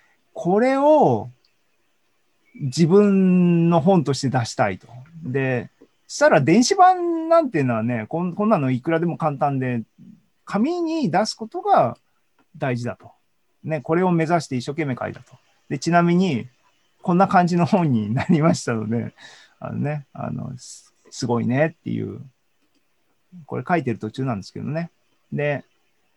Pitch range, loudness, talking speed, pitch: 125-185 Hz, -20 LUFS, 280 characters per minute, 160 Hz